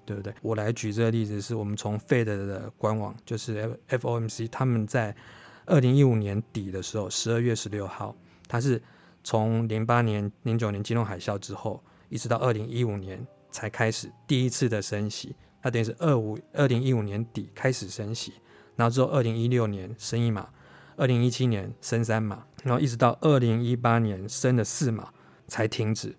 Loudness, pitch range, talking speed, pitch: -27 LUFS, 105-125 Hz, 295 characters per minute, 115 Hz